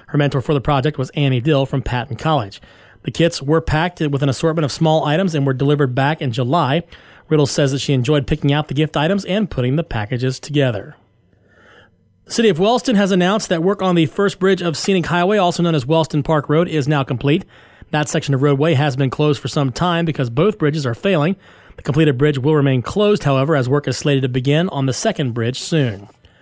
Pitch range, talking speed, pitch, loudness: 135-165 Hz, 225 wpm, 150 Hz, -17 LUFS